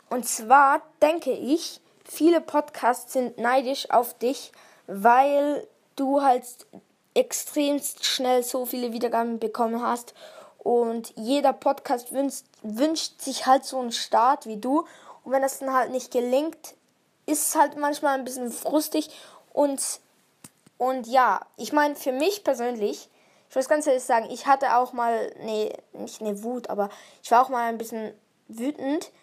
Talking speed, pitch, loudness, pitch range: 155 wpm, 260 Hz, -24 LUFS, 235-285 Hz